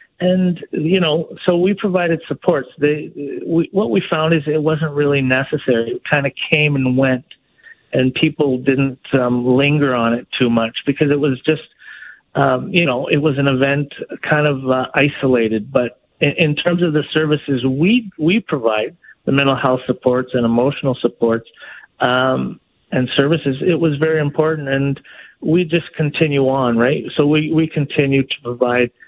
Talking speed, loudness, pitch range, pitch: 170 wpm, -17 LUFS, 130-160 Hz, 145 Hz